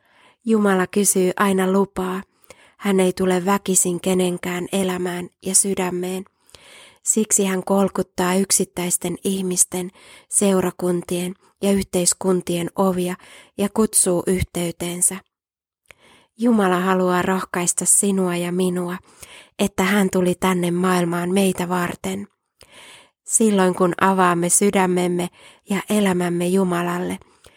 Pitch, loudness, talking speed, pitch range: 185 Hz, -19 LUFS, 95 wpm, 180-195 Hz